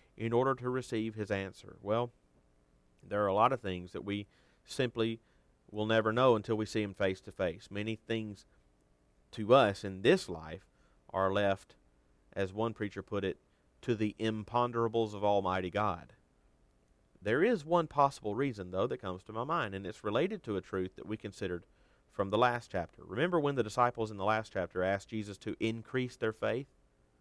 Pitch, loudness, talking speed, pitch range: 105 Hz, -34 LUFS, 185 wpm, 90-115 Hz